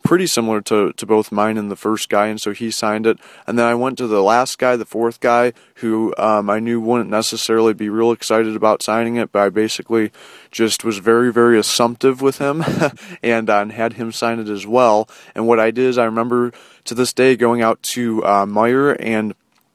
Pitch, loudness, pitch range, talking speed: 115 Hz, -17 LUFS, 110-120 Hz, 220 wpm